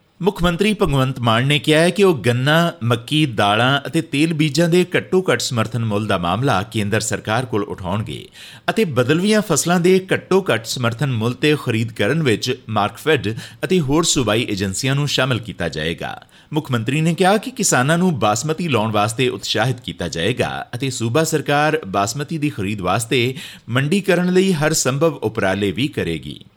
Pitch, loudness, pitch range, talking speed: 130 Hz, -18 LUFS, 110-160 Hz, 165 wpm